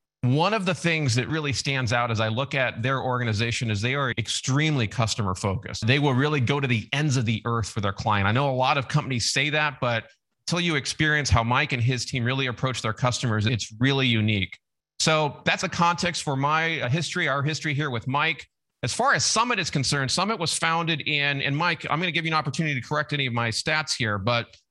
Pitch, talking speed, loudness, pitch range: 135 Hz, 235 wpm, -24 LUFS, 120-155 Hz